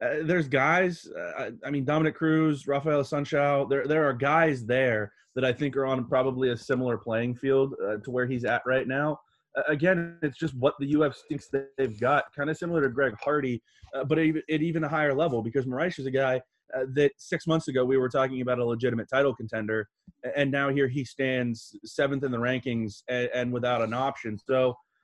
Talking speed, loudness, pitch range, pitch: 215 wpm, -27 LUFS, 125-150 Hz, 135 Hz